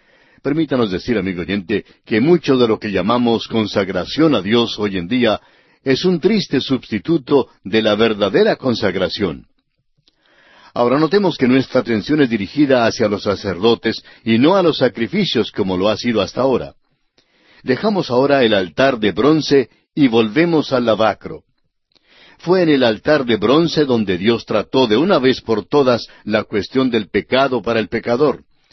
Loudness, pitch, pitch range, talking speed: -16 LUFS, 125 Hz, 110-145 Hz, 160 wpm